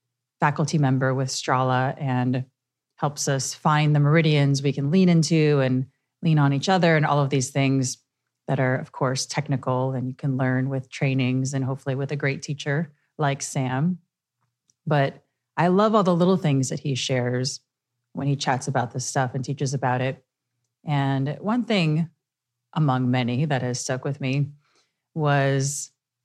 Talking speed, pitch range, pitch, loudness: 170 wpm, 130-150 Hz, 135 Hz, -23 LUFS